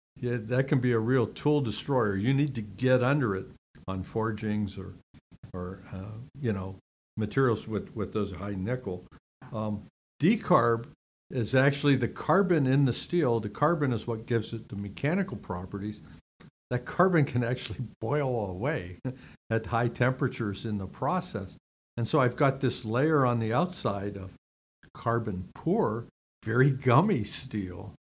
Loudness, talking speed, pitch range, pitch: -29 LUFS, 155 wpm, 100-135 Hz, 115 Hz